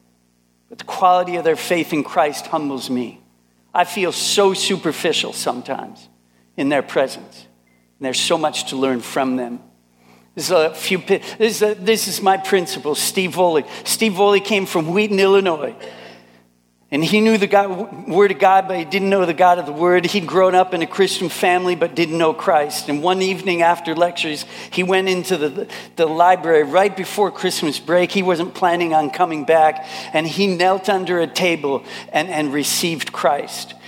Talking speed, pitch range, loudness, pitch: 180 wpm, 145-190 Hz, -18 LUFS, 175 Hz